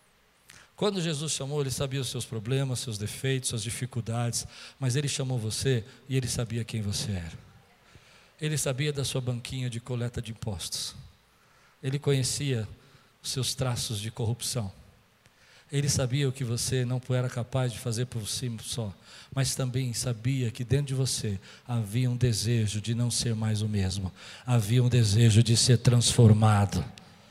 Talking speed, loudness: 160 wpm, -28 LUFS